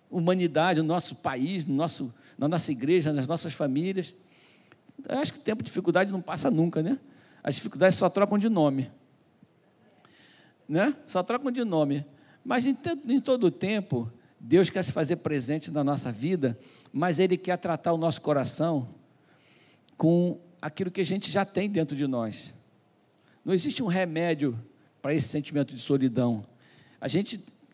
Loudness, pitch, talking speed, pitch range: -27 LUFS, 165 Hz, 165 wpm, 145-185 Hz